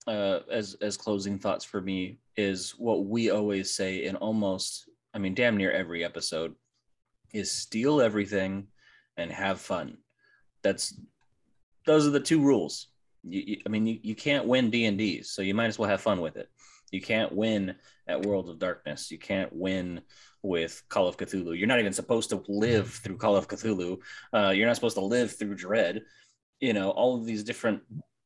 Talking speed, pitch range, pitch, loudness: 185 wpm, 95-115 Hz, 105 Hz, -29 LUFS